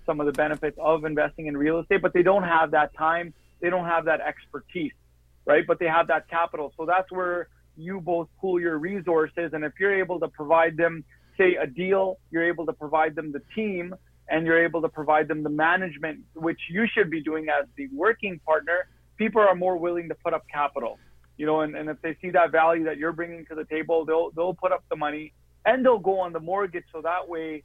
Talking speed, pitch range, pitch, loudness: 230 wpm, 155-180 Hz, 165 Hz, -25 LUFS